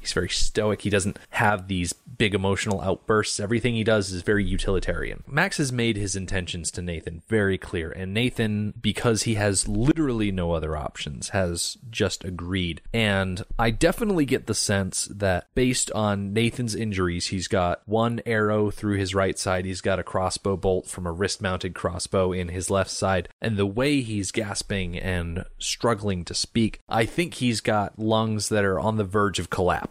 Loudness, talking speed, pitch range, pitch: -25 LUFS, 185 wpm, 95-110 Hz, 100 Hz